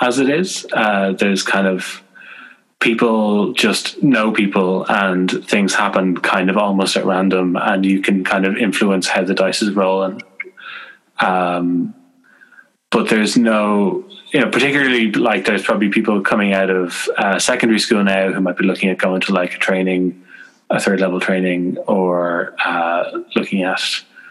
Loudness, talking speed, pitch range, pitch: -16 LUFS, 165 wpm, 95-110 Hz, 95 Hz